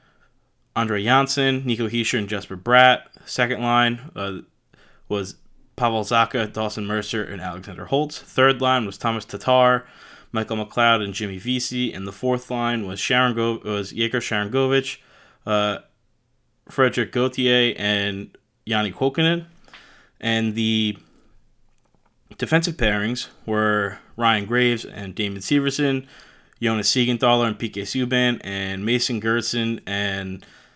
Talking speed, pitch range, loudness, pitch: 125 wpm, 105-125 Hz, -22 LUFS, 115 Hz